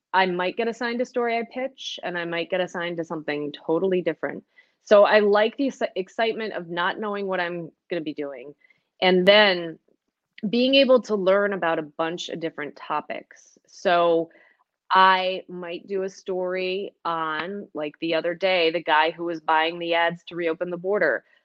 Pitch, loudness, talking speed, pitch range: 180 Hz, -23 LUFS, 180 wpm, 165-205 Hz